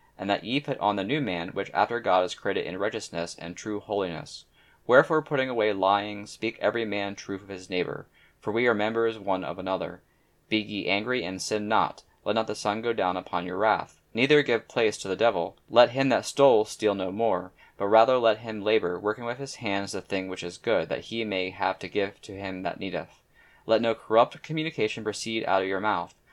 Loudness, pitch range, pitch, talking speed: -27 LUFS, 95-115 Hz, 105 Hz, 220 wpm